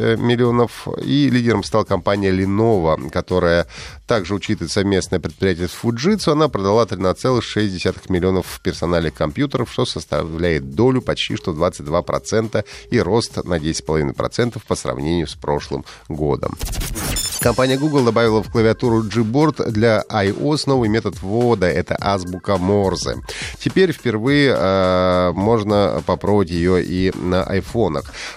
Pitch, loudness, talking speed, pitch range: 100 Hz, -18 LUFS, 120 wpm, 90-115 Hz